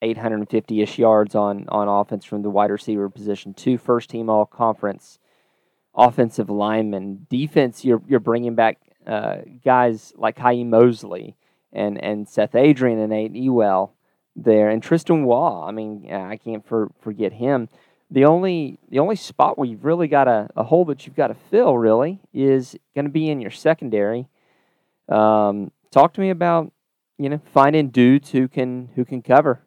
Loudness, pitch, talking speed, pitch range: -19 LUFS, 120 Hz, 170 wpm, 105-135 Hz